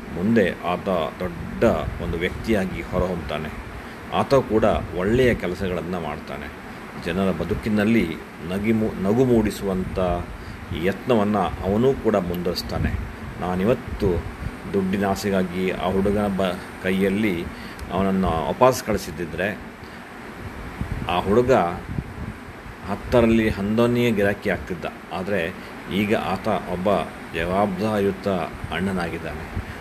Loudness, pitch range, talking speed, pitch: -23 LUFS, 90-110 Hz, 85 wpm, 100 Hz